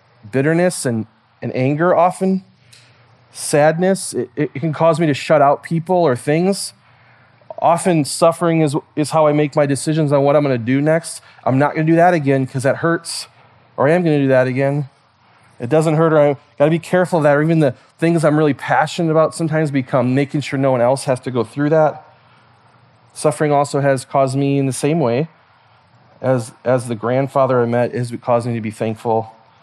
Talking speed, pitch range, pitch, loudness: 210 wpm, 125-155 Hz, 140 Hz, -16 LUFS